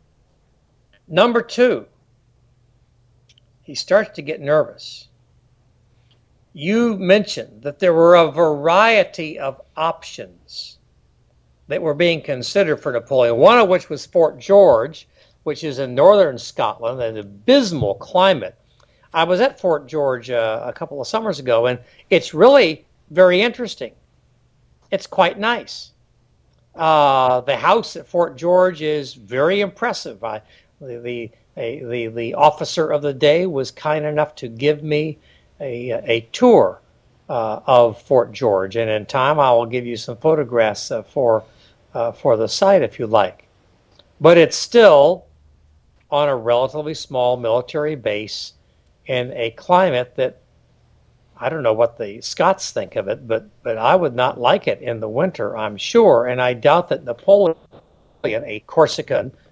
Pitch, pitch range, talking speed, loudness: 135 Hz, 120-165 Hz, 145 wpm, -17 LUFS